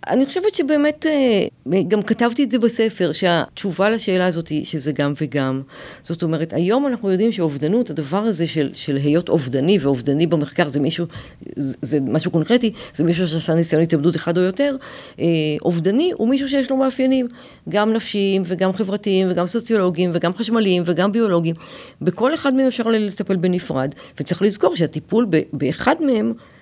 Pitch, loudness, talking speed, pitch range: 185 Hz, -19 LUFS, 160 wpm, 165-230 Hz